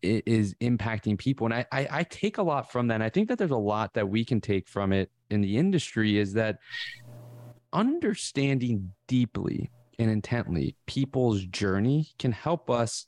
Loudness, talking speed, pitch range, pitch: -28 LUFS, 180 wpm, 105-135 Hz, 120 Hz